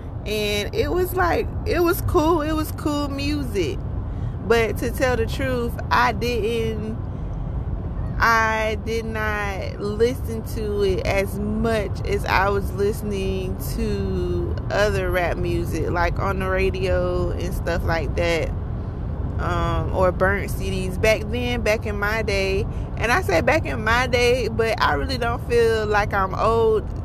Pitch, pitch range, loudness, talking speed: 100 Hz, 95-115 Hz, -22 LUFS, 150 wpm